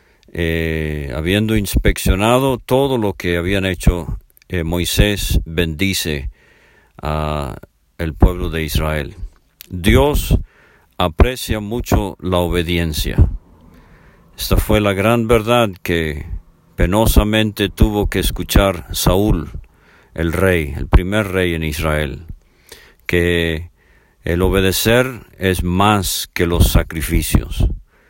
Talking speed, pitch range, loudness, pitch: 100 wpm, 80-100 Hz, -17 LUFS, 90 Hz